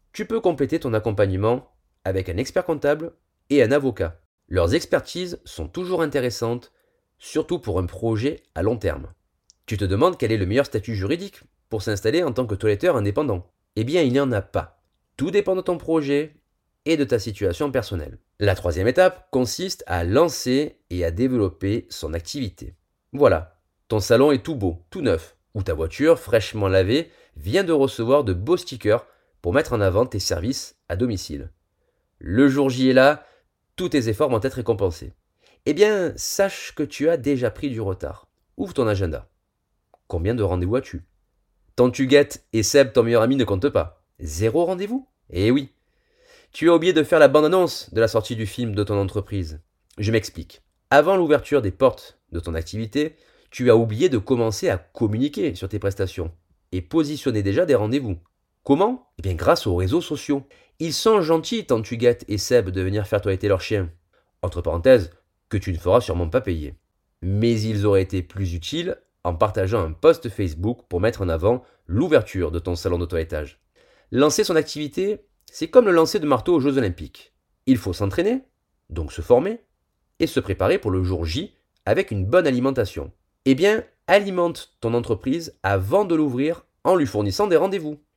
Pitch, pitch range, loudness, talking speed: 115 Hz, 95-150 Hz, -22 LUFS, 185 wpm